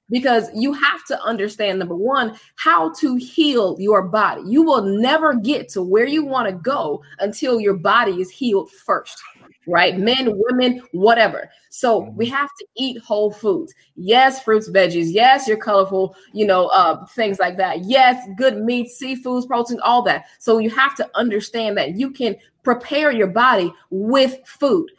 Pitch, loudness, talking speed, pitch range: 230 Hz, -18 LUFS, 170 wpm, 200-265 Hz